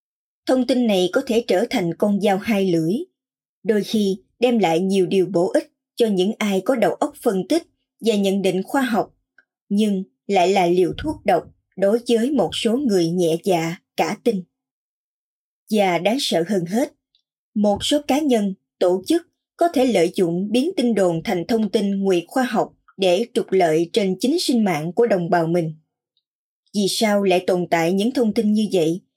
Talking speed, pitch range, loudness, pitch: 190 wpm, 180-245 Hz, -20 LUFS, 205 Hz